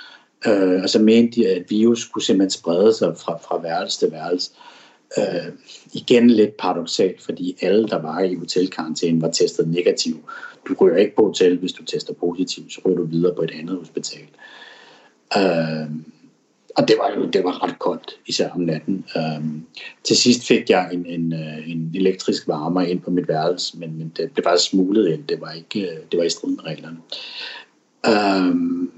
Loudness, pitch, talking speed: -20 LUFS, 95 Hz, 190 wpm